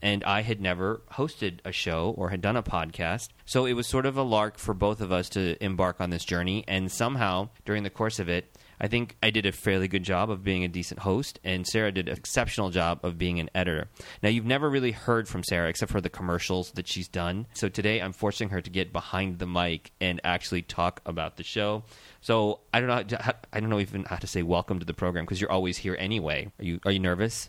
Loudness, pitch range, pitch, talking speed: -29 LUFS, 90-110 Hz, 95 Hz, 255 wpm